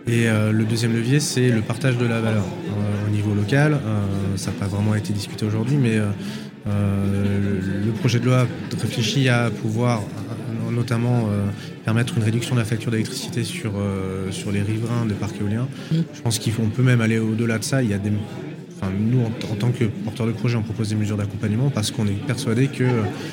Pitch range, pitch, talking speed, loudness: 105-120 Hz, 110 Hz, 205 wpm, -22 LUFS